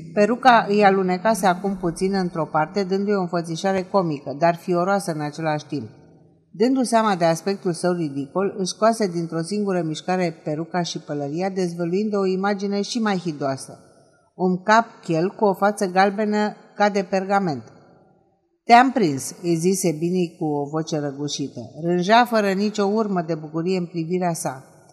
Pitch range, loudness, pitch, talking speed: 165-200 Hz, -21 LUFS, 180 Hz, 150 wpm